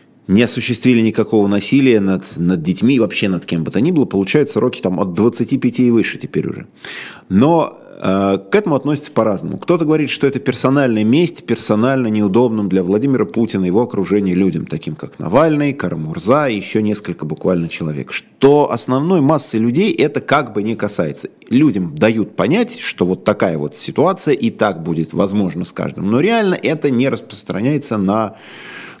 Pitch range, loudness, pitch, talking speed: 95-130 Hz, -16 LUFS, 110 Hz, 170 wpm